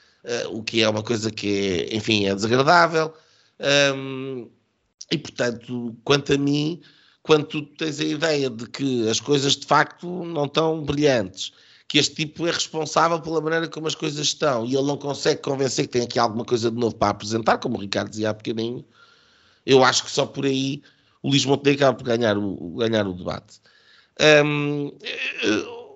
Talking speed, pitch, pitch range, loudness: 180 wpm, 135 Hz, 115-150 Hz, -22 LUFS